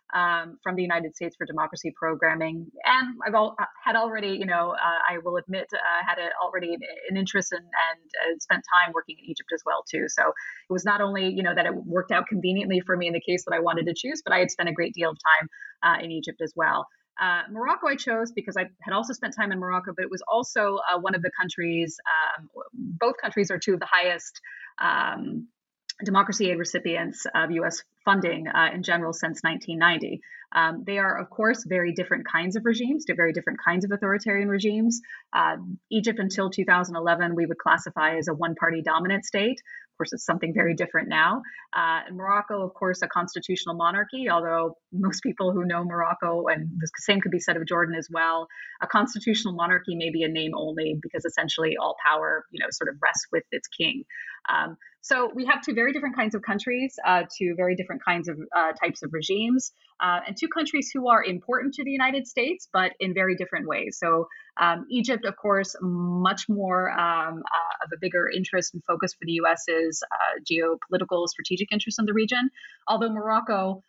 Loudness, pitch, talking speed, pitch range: -25 LUFS, 185 Hz, 210 wpm, 170-215 Hz